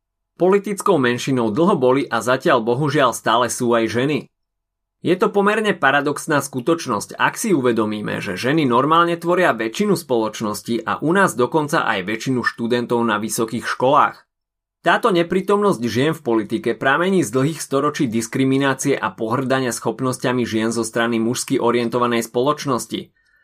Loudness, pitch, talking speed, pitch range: -19 LUFS, 125 Hz, 140 wpm, 115-150 Hz